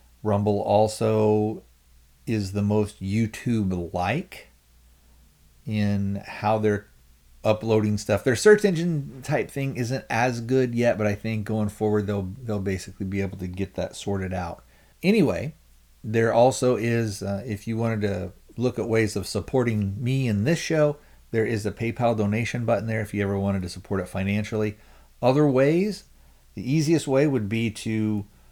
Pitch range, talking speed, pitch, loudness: 95-115 Hz, 160 wpm, 105 Hz, -25 LUFS